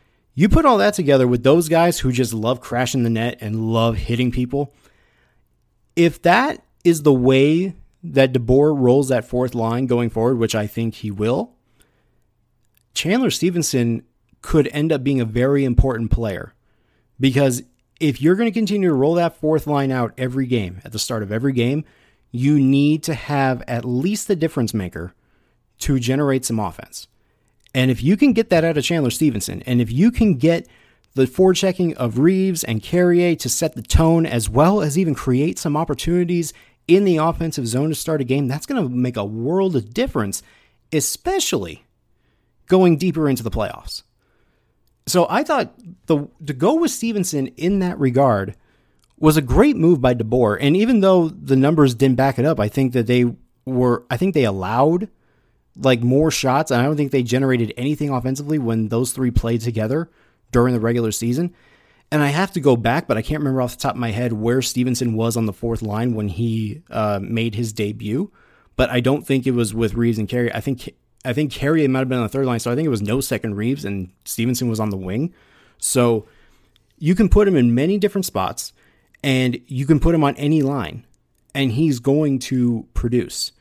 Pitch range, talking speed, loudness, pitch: 115-155 Hz, 200 wpm, -19 LUFS, 130 Hz